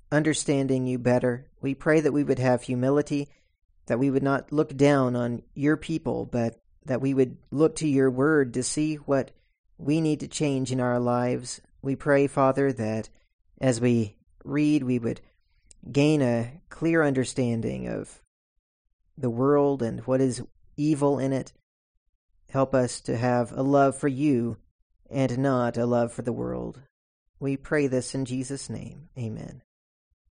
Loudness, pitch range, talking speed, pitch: -26 LUFS, 115-140 Hz, 160 wpm, 130 Hz